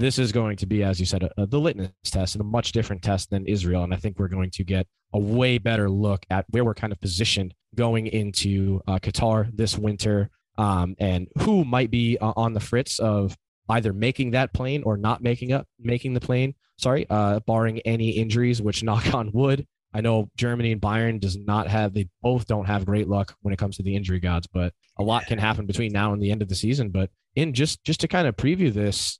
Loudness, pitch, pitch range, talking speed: -24 LUFS, 105 Hz, 100-120 Hz, 240 wpm